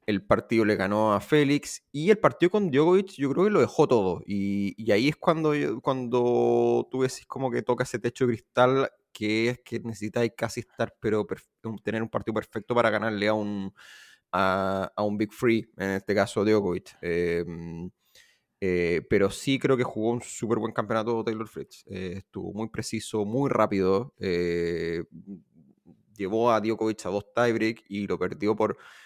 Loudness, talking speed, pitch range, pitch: -26 LUFS, 180 wpm, 100-120 Hz, 110 Hz